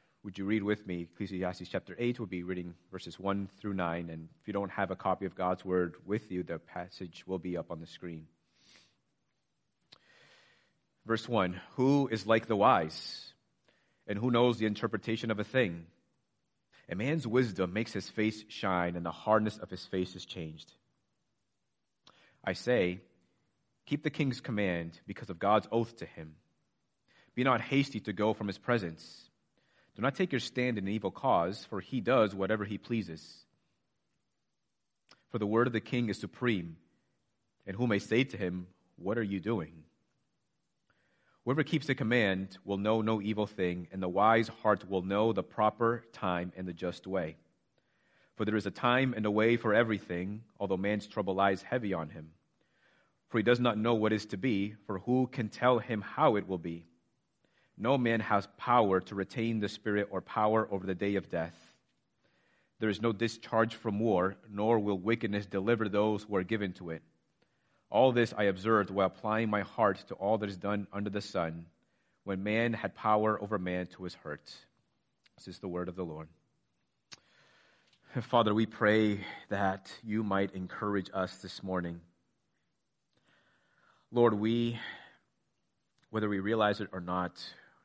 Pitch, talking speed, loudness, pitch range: 100 Hz, 175 wpm, -32 LUFS, 90-115 Hz